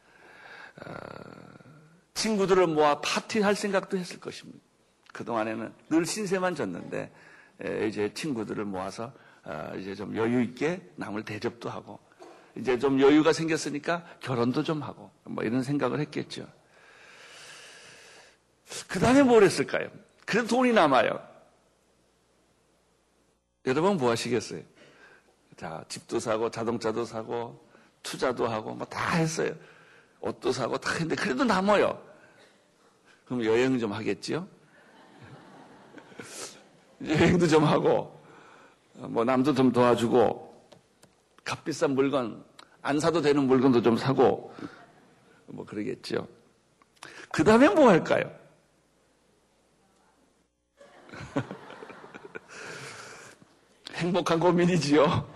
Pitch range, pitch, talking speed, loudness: 120-175 Hz, 145 Hz, 215 characters per minute, -26 LUFS